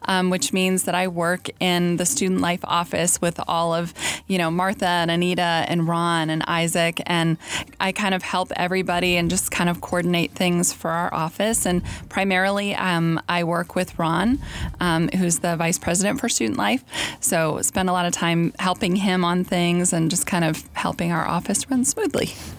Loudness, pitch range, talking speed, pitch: -21 LUFS, 170-185 Hz, 190 wpm, 175 Hz